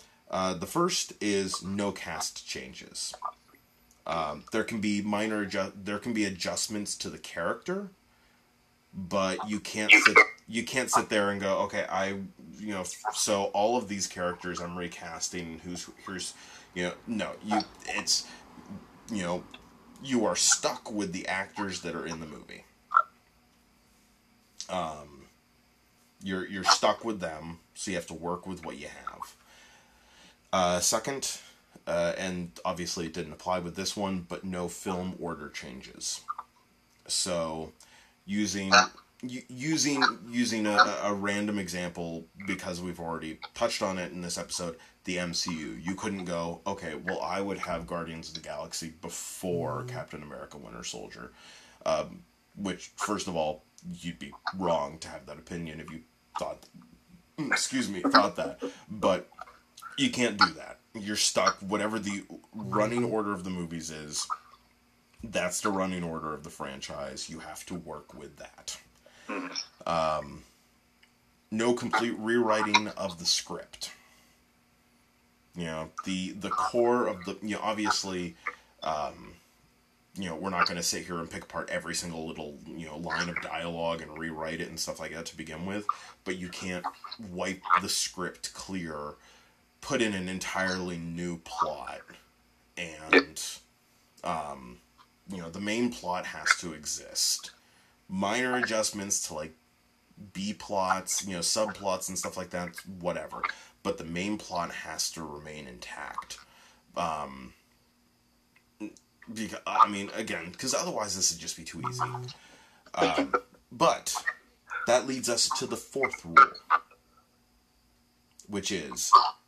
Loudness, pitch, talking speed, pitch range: -30 LUFS, 95 Hz, 145 wpm, 85-105 Hz